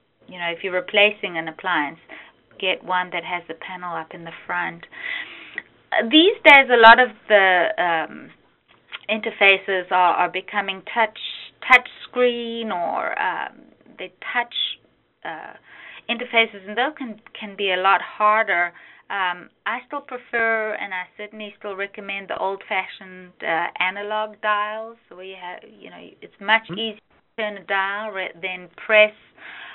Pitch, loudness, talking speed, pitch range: 205 Hz, -20 LUFS, 150 wpm, 185-225 Hz